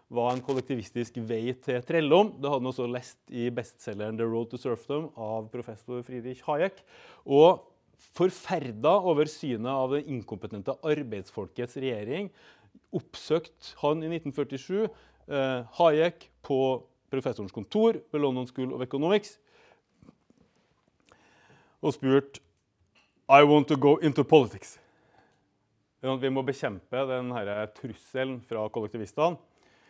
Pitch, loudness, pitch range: 130 Hz, -28 LUFS, 120-150 Hz